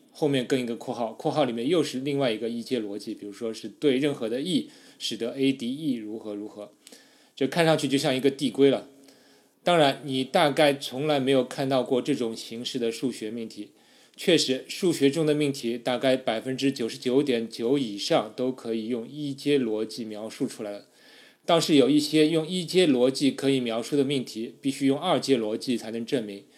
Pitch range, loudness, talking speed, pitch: 115-140 Hz, -26 LUFS, 300 characters per minute, 130 Hz